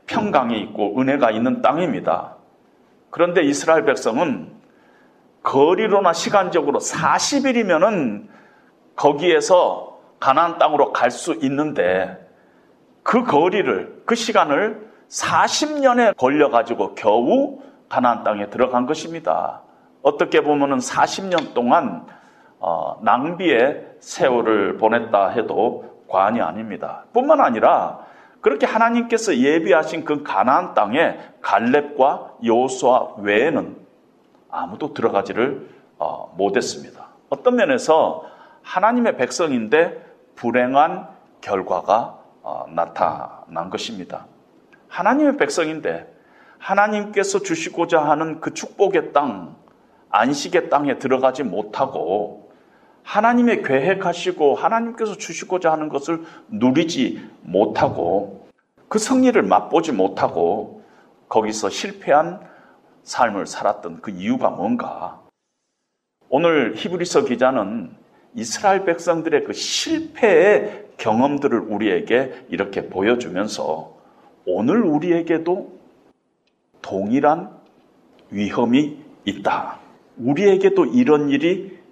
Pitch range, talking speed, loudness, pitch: 155-260 Hz, 240 characters per minute, -19 LUFS, 195 Hz